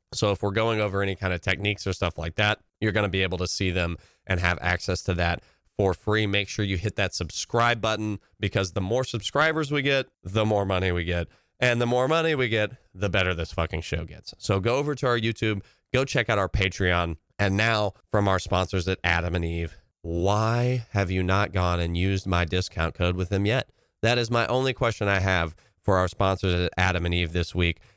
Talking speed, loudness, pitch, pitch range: 230 wpm, -25 LUFS, 100 Hz, 90-110 Hz